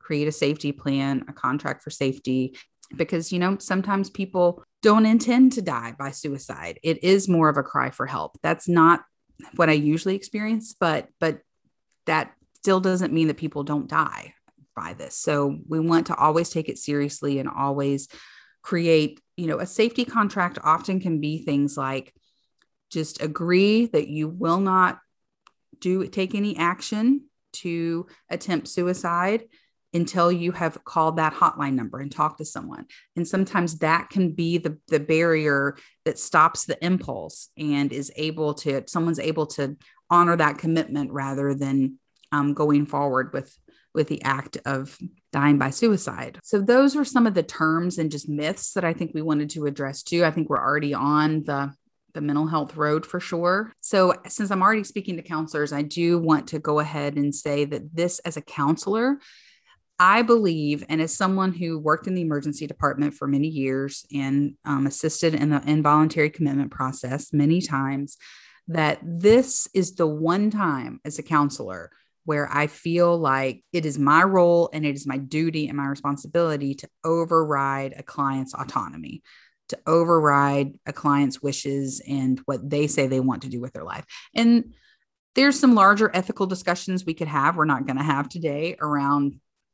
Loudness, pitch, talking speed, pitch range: -23 LUFS, 155 Hz, 175 wpm, 145-180 Hz